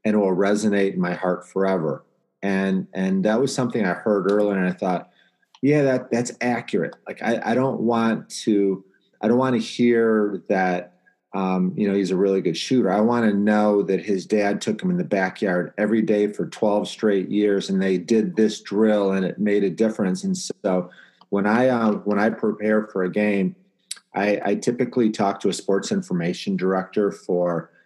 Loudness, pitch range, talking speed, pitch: -22 LUFS, 95-115 Hz, 200 wpm, 105 Hz